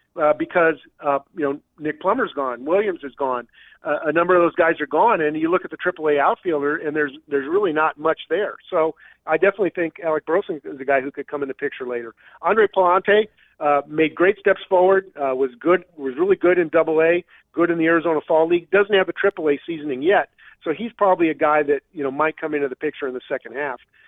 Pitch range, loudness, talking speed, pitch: 145-180 Hz, -20 LUFS, 235 wpm, 160 Hz